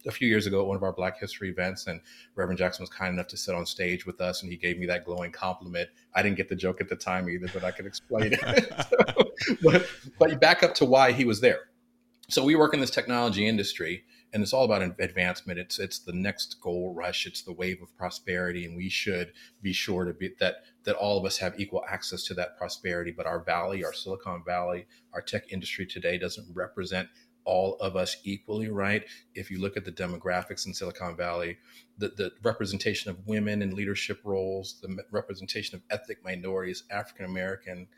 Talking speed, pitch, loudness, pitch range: 215 wpm, 95 Hz, -29 LUFS, 90-100 Hz